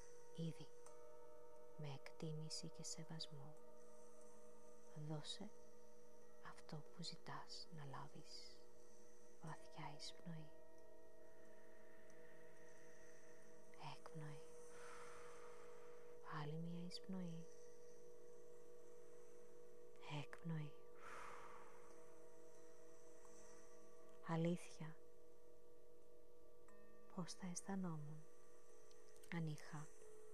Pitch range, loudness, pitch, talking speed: 155-165 Hz, -55 LUFS, 160 Hz, 45 wpm